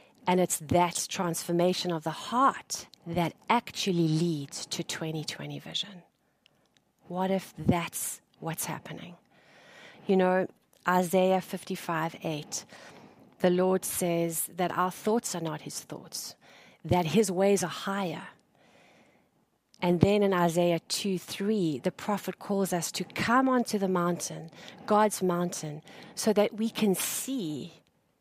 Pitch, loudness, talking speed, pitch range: 180 Hz, -29 LUFS, 130 wpm, 170-195 Hz